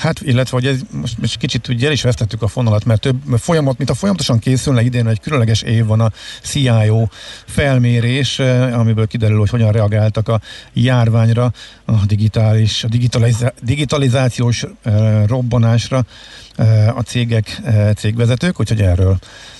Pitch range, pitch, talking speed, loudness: 110-125 Hz, 115 Hz, 145 wpm, -15 LUFS